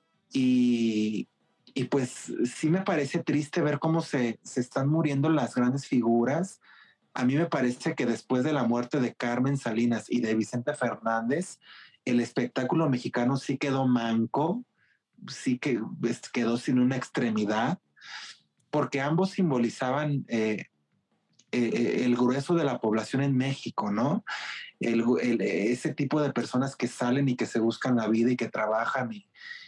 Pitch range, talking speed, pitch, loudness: 120-145 Hz, 155 wpm, 125 Hz, -28 LUFS